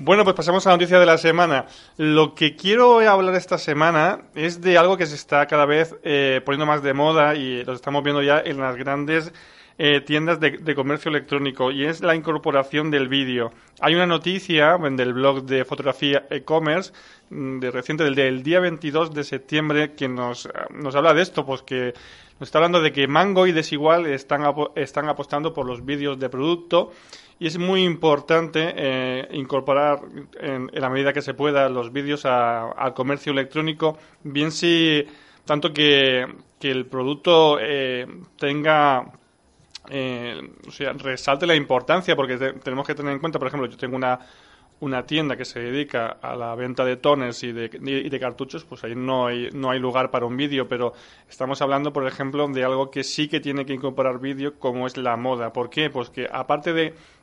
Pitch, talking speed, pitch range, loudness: 145 Hz, 195 wpm, 130-155 Hz, -21 LUFS